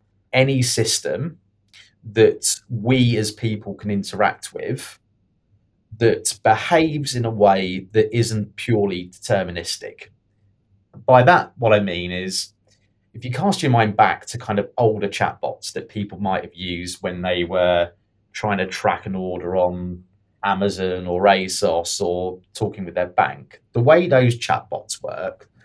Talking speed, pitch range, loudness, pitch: 145 wpm, 95-115 Hz, -20 LUFS, 105 Hz